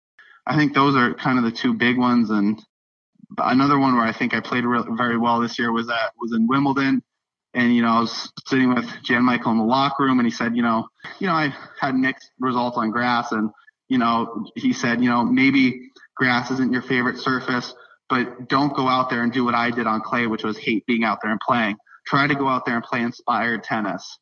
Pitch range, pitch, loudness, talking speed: 115-130 Hz, 125 Hz, -21 LUFS, 235 wpm